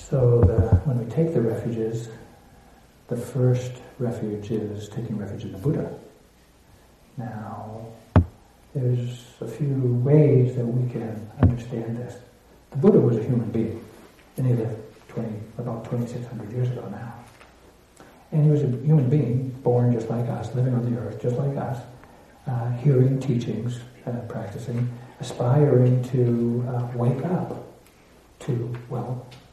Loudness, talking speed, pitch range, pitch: -24 LUFS, 140 wpm, 115-125 Hz, 120 Hz